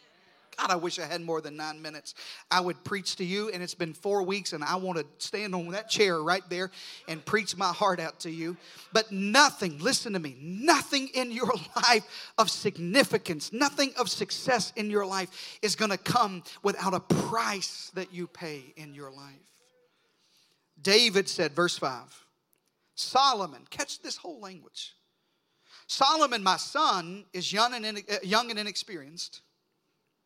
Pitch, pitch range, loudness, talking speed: 190 Hz, 175-220 Hz, -28 LUFS, 165 wpm